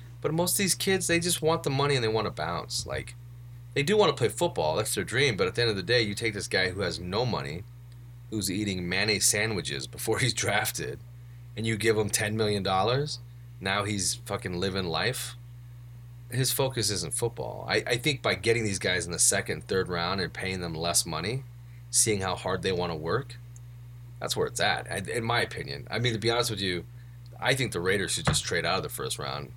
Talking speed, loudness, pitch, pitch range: 225 wpm, -27 LUFS, 120 Hz, 105-125 Hz